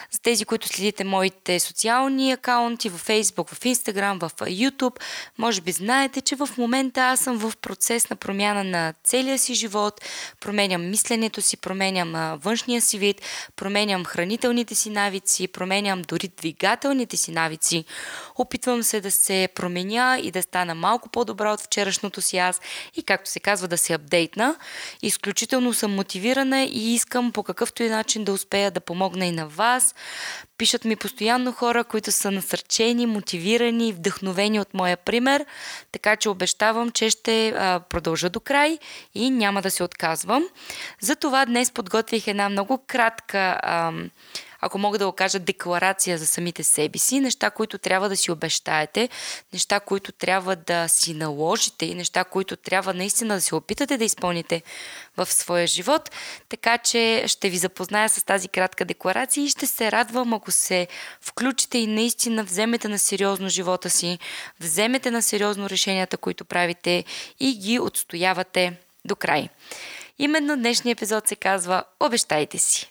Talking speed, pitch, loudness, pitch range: 155 wpm, 205 Hz, -22 LUFS, 185-235 Hz